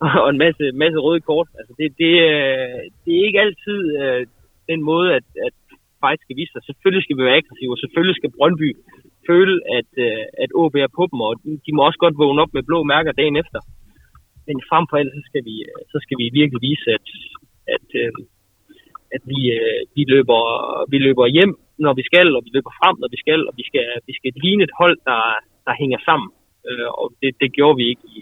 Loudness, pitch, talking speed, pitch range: -17 LUFS, 150 Hz, 220 wpm, 135-170 Hz